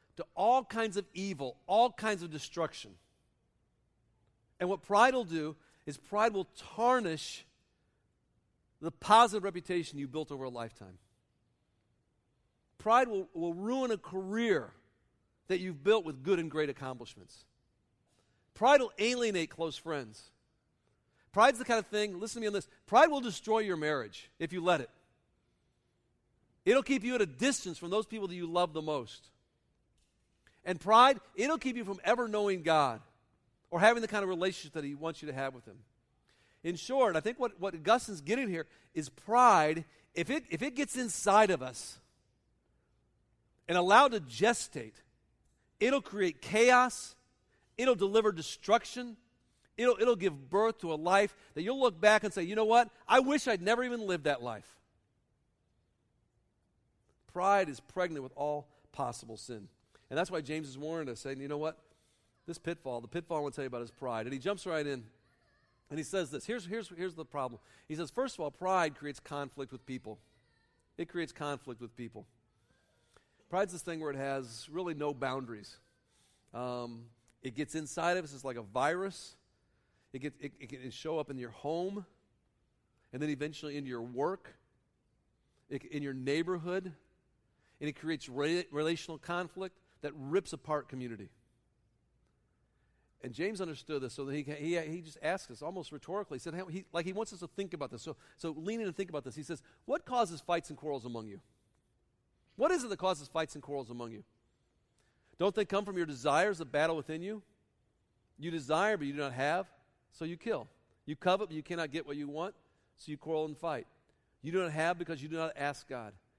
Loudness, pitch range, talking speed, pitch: -33 LUFS, 130-195 Hz, 185 wpm, 160 Hz